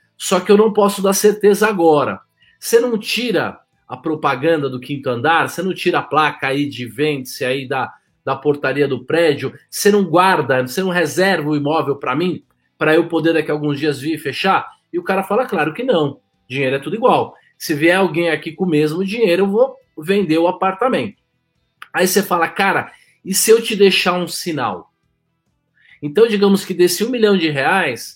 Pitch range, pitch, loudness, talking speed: 150-200 Hz, 175 Hz, -16 LUFS, 195 wpm